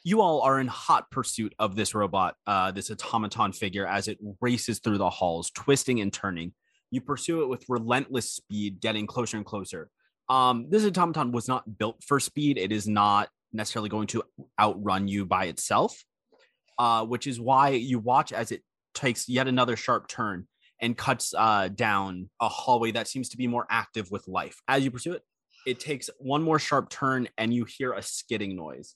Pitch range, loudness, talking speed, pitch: 105-130 Hz, -27 LUFS, 195 wpm, 115 Hz